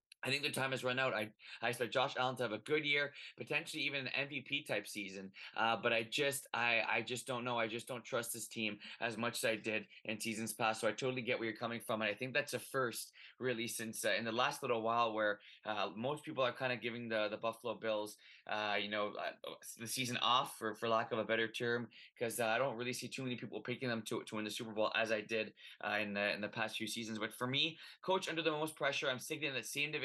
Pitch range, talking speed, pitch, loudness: 110-130 Hz, 270 wpm, 115 Hz, -38 LUFS